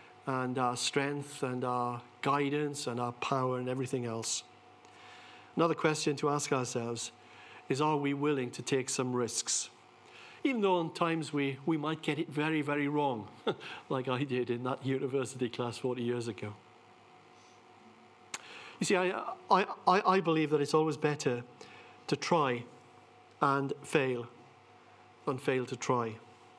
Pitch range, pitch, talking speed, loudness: 120-150 Hz, 130 Hz, 145 wpm, -33 LUFS